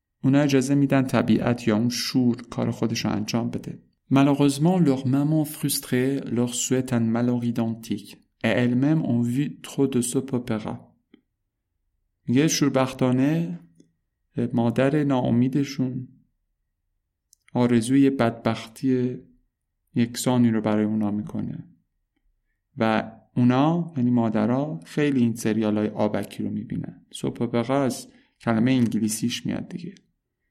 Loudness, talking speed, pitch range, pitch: -23 LUFS, 100 wpm, 110-135 Hz, 120 Hz